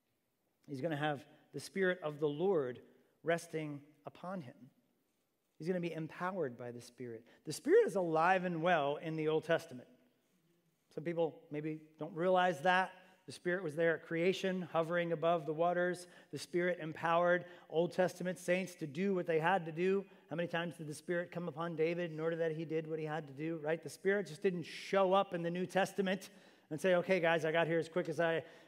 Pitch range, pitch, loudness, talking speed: 155-180 Hz, 170 Hz, -36 LUFS, 210 wpm